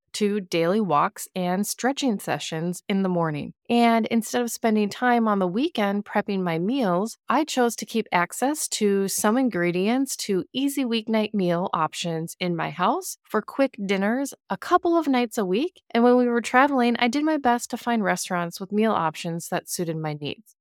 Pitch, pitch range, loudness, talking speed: 215 Hz, 180-245 Hz, -24 LUFS, 185 wpm